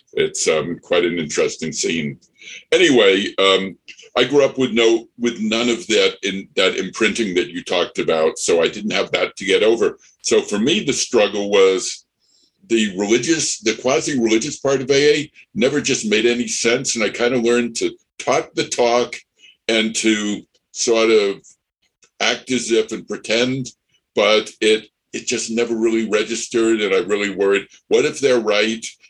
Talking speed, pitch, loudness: 170 wpm, 120 Hz, -18 LUFS